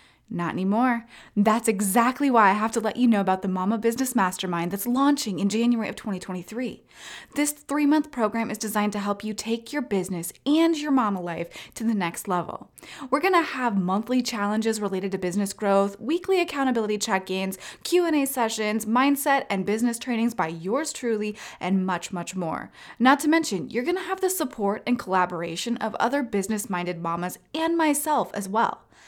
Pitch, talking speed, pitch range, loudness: 220 Hz, 175 wpm, 195-265 Hz, -25 LUFS